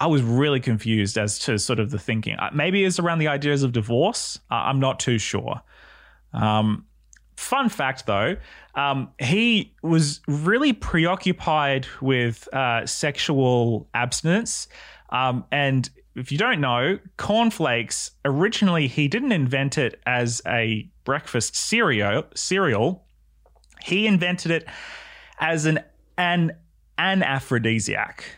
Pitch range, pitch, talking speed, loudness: 120-170 Hz, 140 Hz, 125 wpm, -22 LUFS